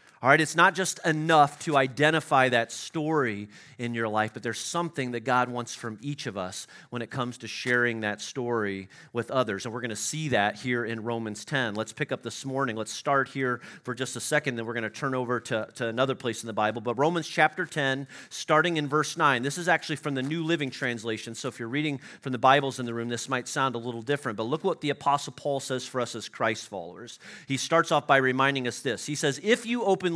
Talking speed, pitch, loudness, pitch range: 240 wpm, 130 Hz, -27 LUFS, 115-150 Hz